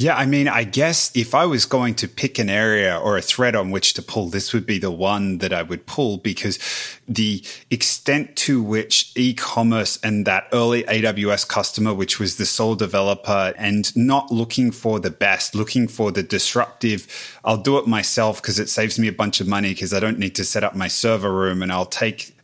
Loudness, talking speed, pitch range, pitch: -19 LUFS, 215 wpm, 100-115 Hz, 110 Hz